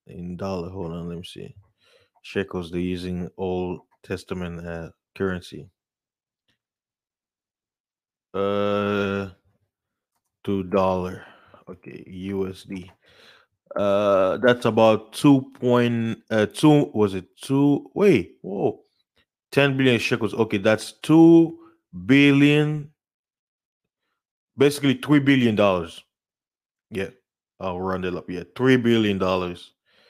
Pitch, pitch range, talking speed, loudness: 100 Hz, 95-130 Hz, 100 wpm, -21 LUFS